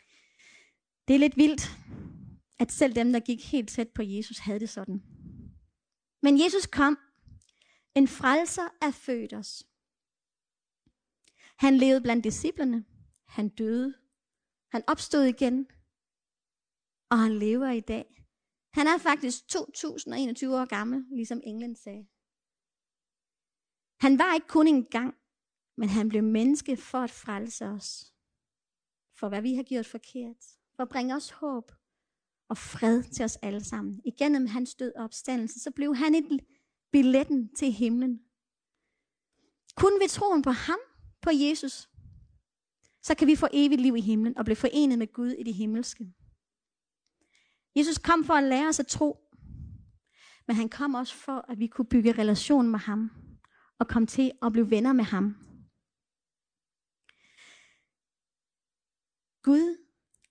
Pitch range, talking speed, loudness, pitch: 230-285 Hz, 140 wpm, -27 LUFS, 255 Hz